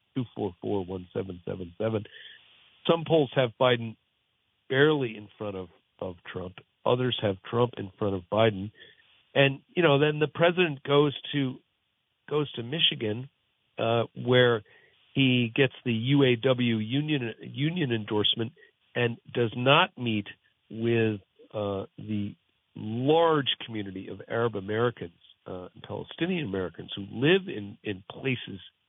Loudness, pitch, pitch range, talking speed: -27 LUFS, 115 Hz, 105-140 Hz, 135 wpm